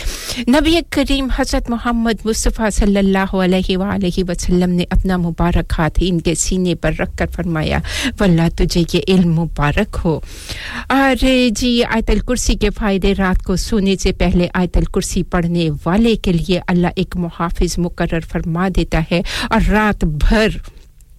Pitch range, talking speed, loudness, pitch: 175-220 Hz, 145 wpm, -16 LUFS, 185 Hz